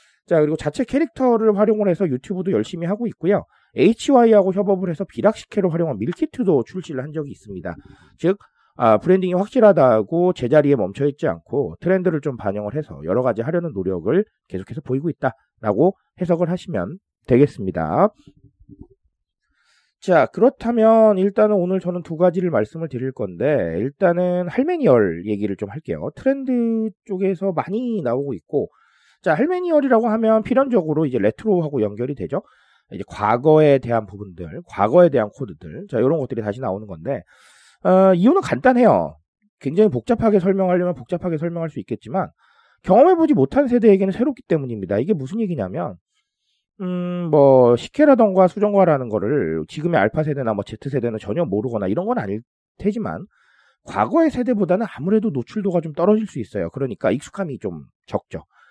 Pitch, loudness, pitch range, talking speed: 180 Hz, -19 LUFS, 130-210 Hz, 375 characters per minute